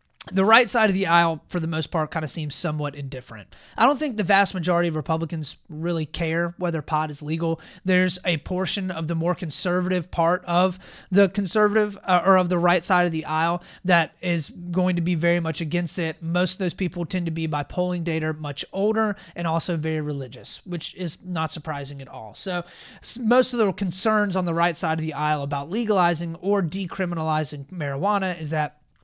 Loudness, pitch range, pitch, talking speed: -24 LUFS, 160-185 Hz, 175 Hz, 205 wpm